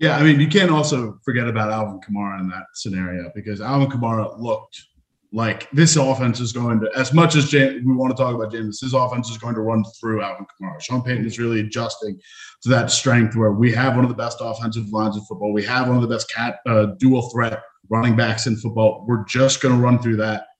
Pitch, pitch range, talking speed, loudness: 115 Hz, 110-130 Hz, 240 wpm, -19 LUFS